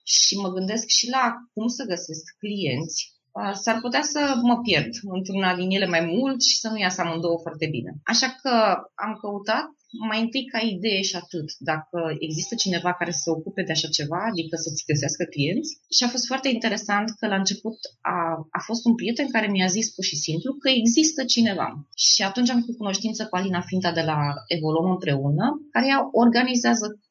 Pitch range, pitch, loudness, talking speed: 170-235 Hz, 200 Hz, -23 LUFS, 190 wpm